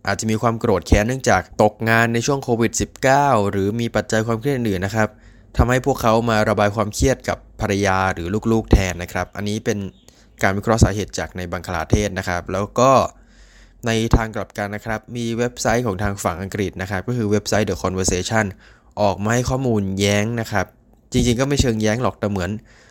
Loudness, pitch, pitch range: -20 LUFS, 105 Hz, 100-115 Hz